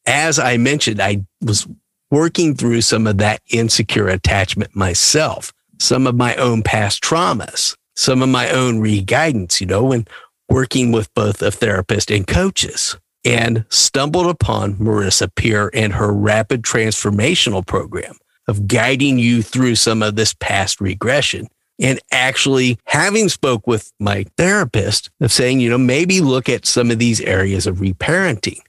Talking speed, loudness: 155 wpm, -15 LUFS